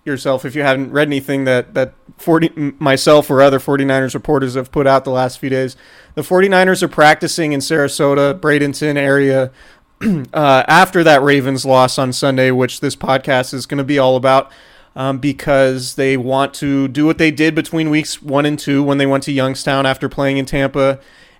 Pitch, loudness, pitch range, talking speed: 140 Hz, -14 LUFS, 135-150 Hz, 190 wpm